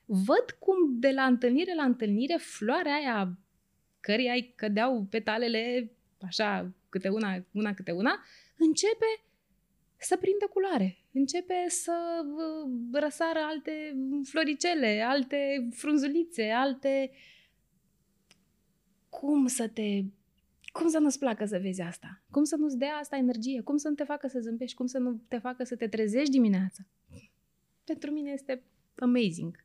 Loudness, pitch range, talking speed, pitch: -30 LUFS, 220-300 Hz, 135 wpm, 260 Hz